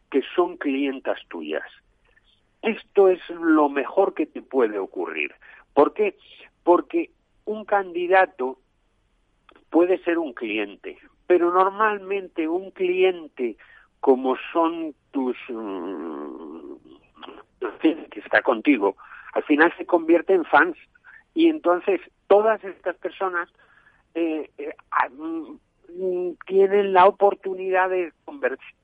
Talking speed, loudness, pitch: 100 wpm, -23 LUFS, 195 Hz